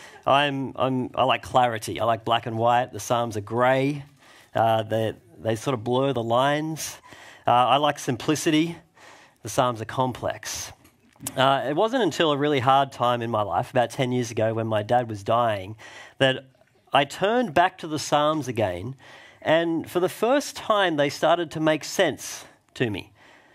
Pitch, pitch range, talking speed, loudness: 130 Hz, 115-150 Hz, 180 wpm, -24 LUFS